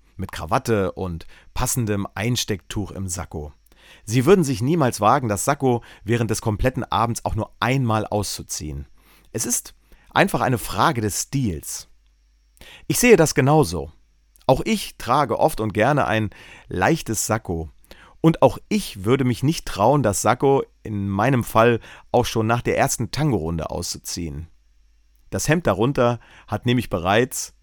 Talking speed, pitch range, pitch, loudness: 145 wpm, 85-125 Hz, 110 Hz, -21 LUFS